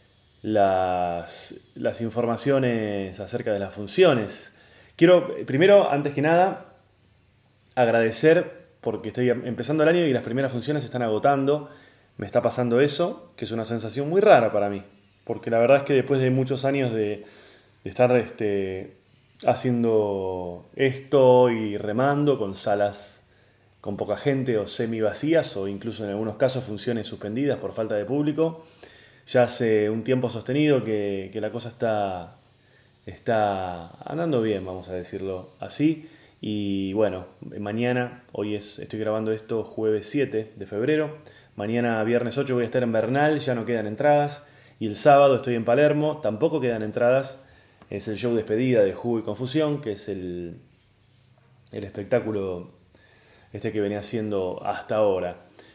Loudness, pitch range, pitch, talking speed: -24 LUFS, 105-135 Hz, 115 Hz, 155 wpm